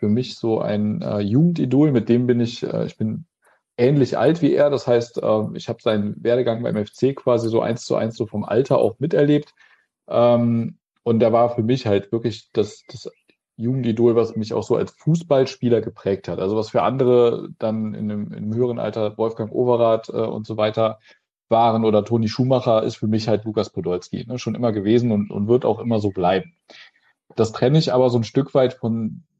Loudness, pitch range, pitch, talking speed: -20 LUFS, 110-125 Hz, 115 Hz, 210 wpm